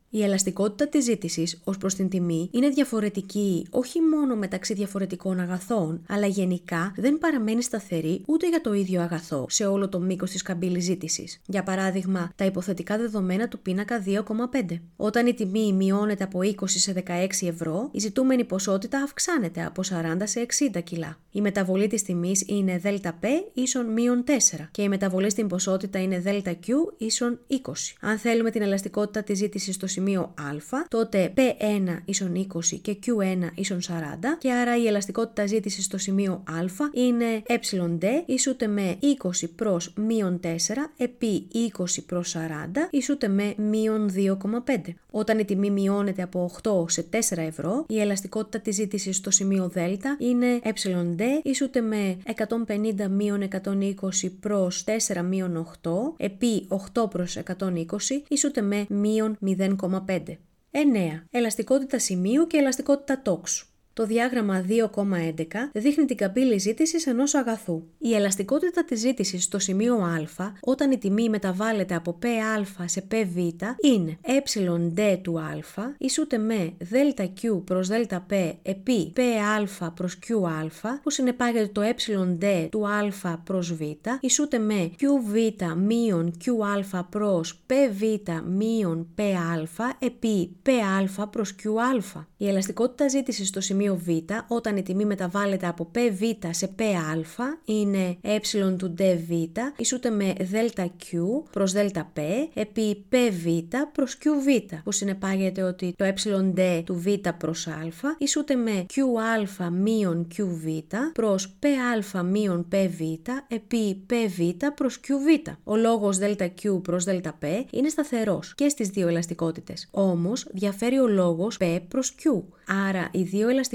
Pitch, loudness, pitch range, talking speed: 200 Hz, -26 LUFS, 180-235 Hz, 140 wpm